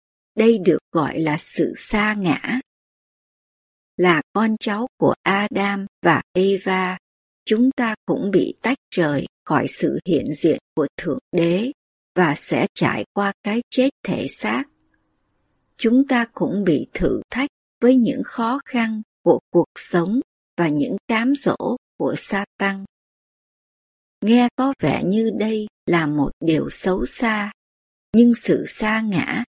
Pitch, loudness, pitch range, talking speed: 215 Hz, -20 LUFS, 185-240 Hz, 140 wpm